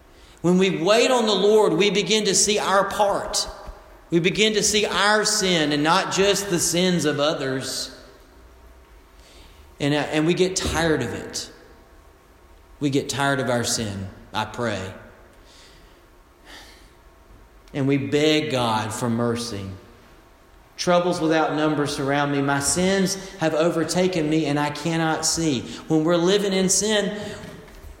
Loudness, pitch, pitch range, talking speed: -21 LUFS, 155 Hz, 120-190 Hz, 140 wpm